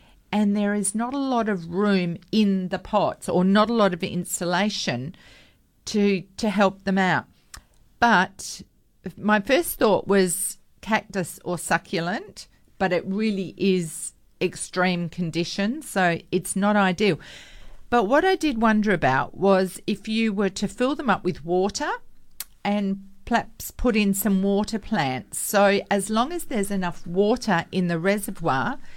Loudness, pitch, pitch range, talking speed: -23 LUFS, 195 Hz, 180-215 Hz, 150 wpm